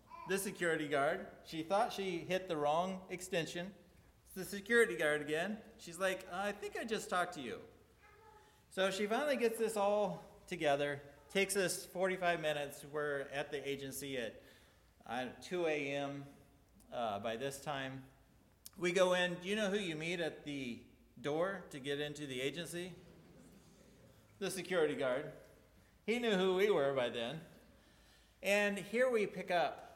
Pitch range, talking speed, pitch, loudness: 145-195 Hz, 160 wpm, 175 Hz, -38 LUFS